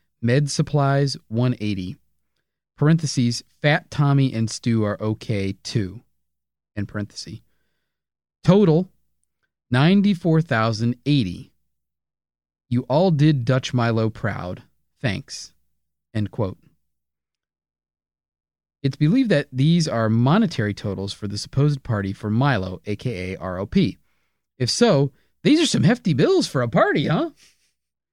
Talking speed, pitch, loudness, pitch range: 105 wpm, 115 Hz, -21 LUFS, 95-140 Hz